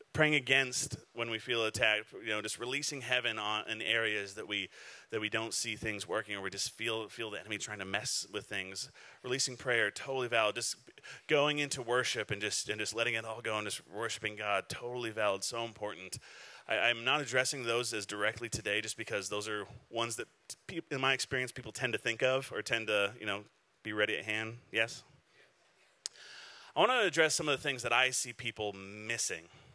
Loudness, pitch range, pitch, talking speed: -34 LUFS, 105-130 Hz, 115 Hz, 210 wpm